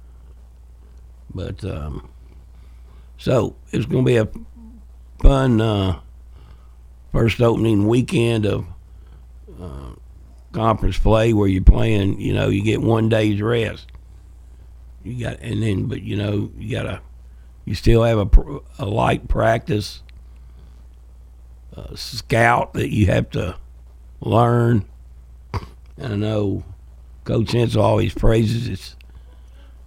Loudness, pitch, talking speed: -20 LUFS, 85 Hz, 120 wpm